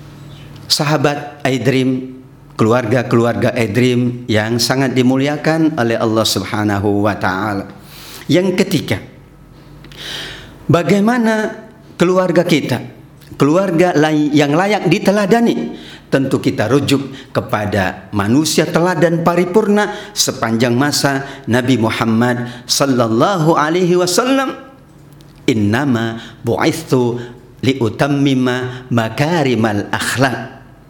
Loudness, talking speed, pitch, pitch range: -15 LUFS, 80 wpm, 135 Hz, 120-155 Hz